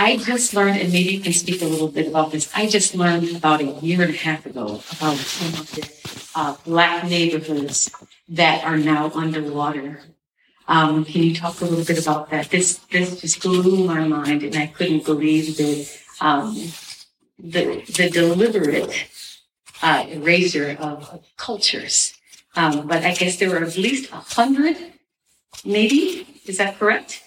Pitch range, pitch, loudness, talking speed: 155-185 Hz, 170 Hz, -20 LUFS, 165 wpm